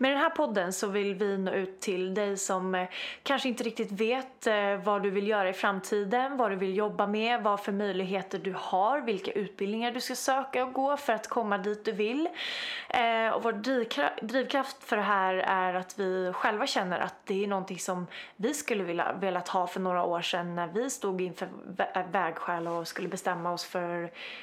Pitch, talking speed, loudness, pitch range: 205 Hz, 195 wpm, -30 LUFS, 185-240 Hz